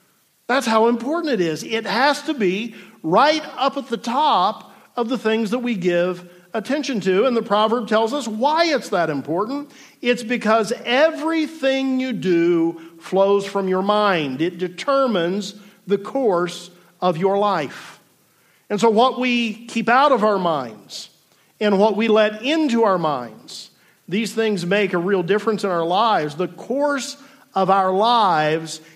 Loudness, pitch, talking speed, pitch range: -19 LUFS, 215 Hz, 160 wpm, 185-255 Hz